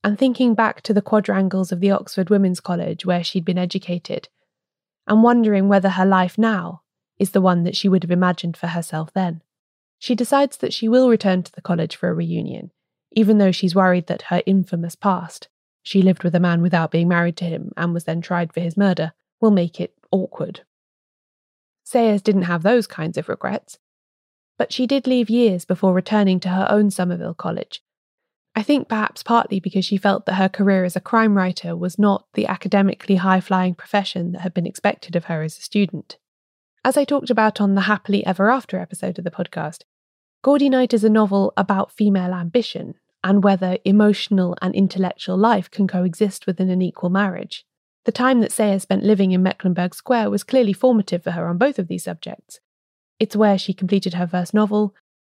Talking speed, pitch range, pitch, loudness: 195 wpm, 180-210 Hz, 190 Hz, -19 LUFS